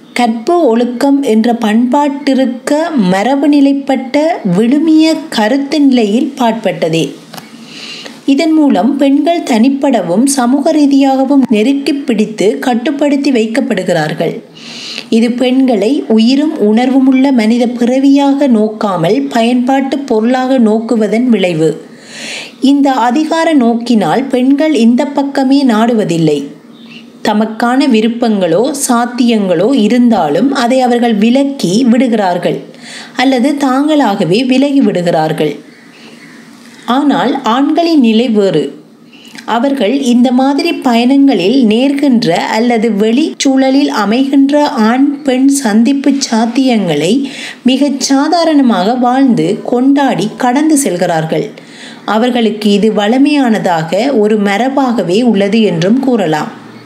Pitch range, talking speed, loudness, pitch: 225-275 Hz, 85 wpm, -10 LUFS, 250 Hz